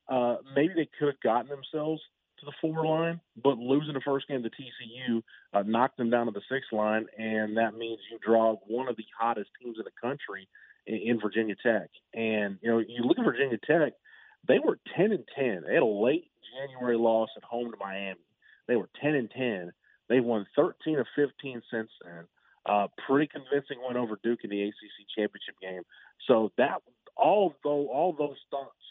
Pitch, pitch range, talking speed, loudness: 120 Hz, 110-140 Hz, 195 wpm, -29 LUFS